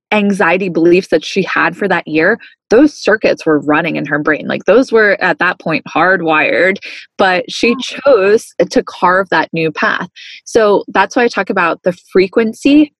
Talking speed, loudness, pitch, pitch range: 175 wpm, -12 LUFS, 190 Hz, 170-230 Hz